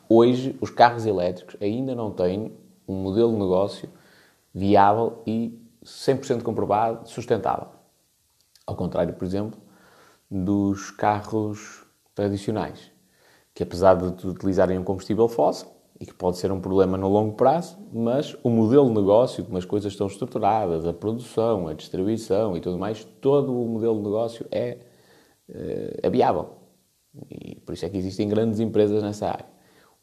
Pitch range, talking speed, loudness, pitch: 95-115 Hz, 150 wpm, -24 LUFS, 105 Hz